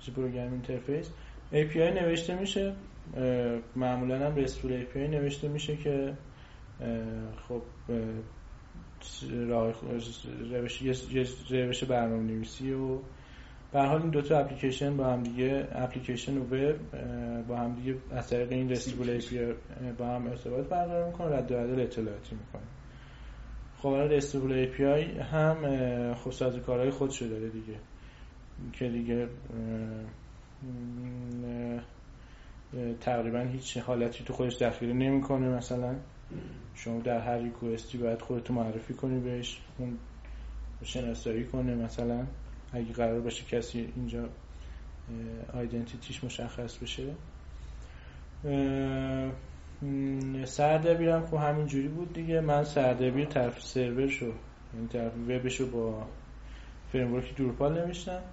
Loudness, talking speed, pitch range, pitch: -33 LUFS, 115 wpm, 115-135 Hz, 125 Hz